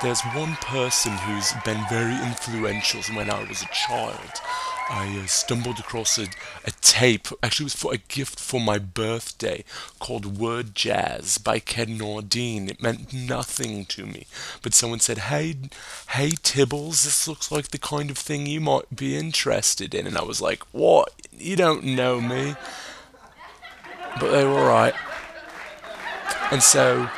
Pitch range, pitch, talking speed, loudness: 110-140 Hz, 120 Hz, 160 wpm, -23 LUFS